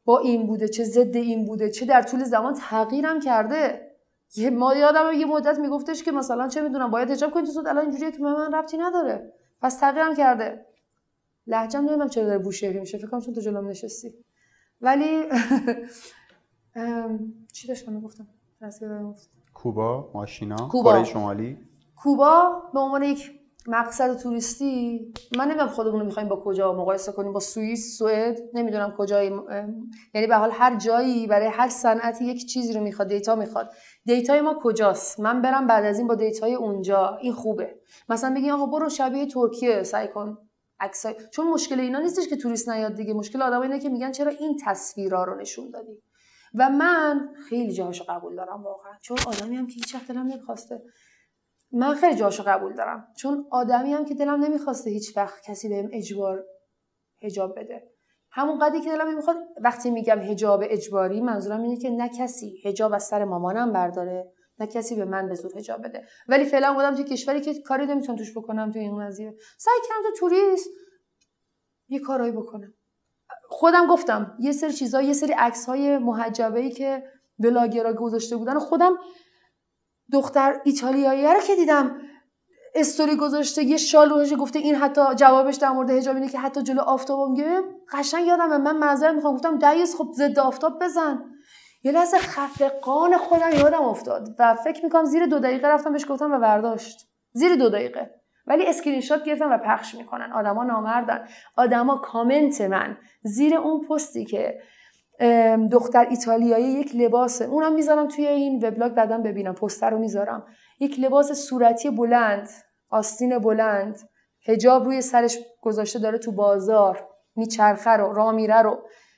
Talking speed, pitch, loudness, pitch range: 165 wpm, 245 Hz, -22 LUFS, 220-285 Hz